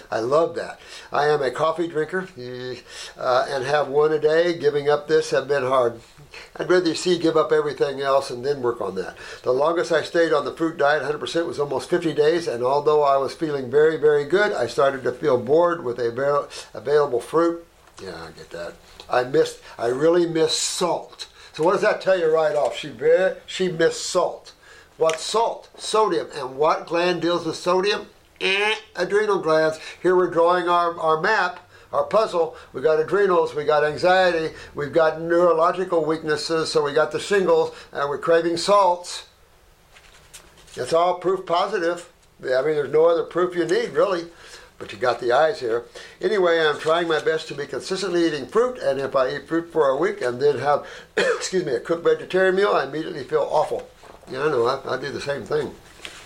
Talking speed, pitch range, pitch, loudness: 195 wpm, 155-205 Hz, 170 Hz, -21 LUFS